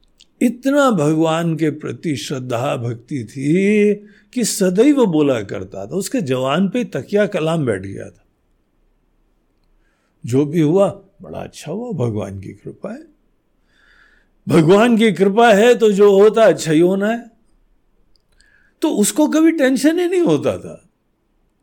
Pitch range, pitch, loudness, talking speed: 145-225 Hz, 195 Hz, -16 LUFS, 135 wpm